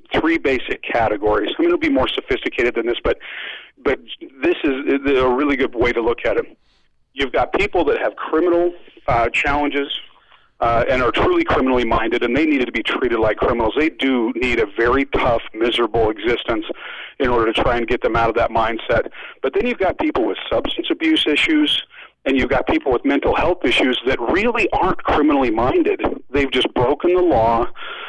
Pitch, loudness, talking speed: 305 Hz, -18 LUFS, 195 wpm